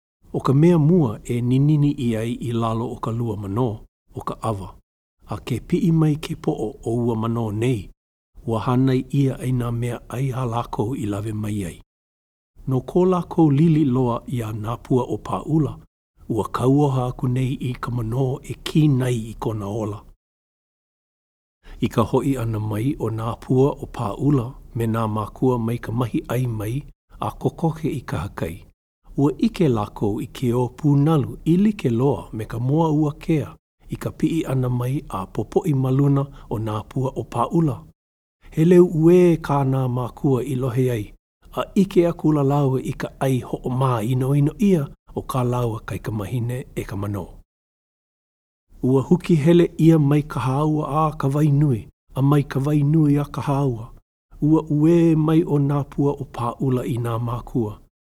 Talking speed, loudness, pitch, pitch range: 185 wpm, -21 LUFS, 130 Hz, 115-150 Hz